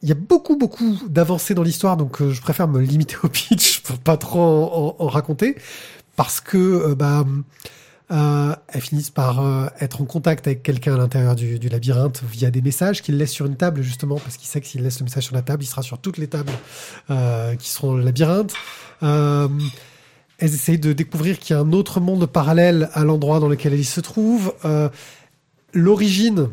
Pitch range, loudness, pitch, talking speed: 135-170 Hz, -19 LUFS, 150 Hz, 215 wpm